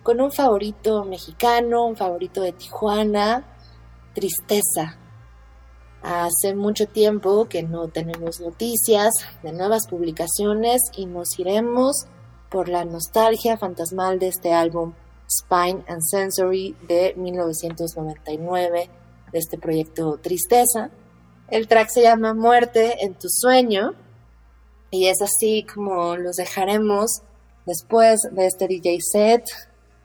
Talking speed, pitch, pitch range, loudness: 115 wpm, 185 Hz, 165-215 Hz, -20 LUFS